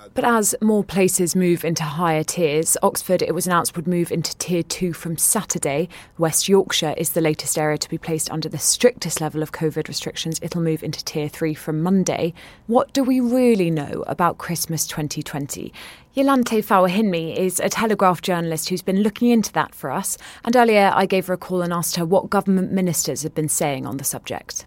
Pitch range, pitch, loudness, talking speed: 160-195 Hz, 170 Hz, -20 LUFS, 200 wpm